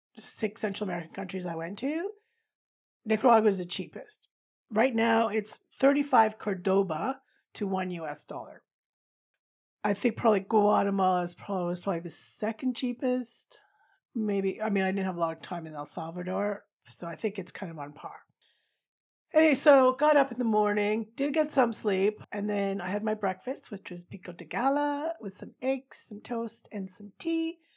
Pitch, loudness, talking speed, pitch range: 210 Hz, -29 LUFS, 180 wpm, 190-255 Hz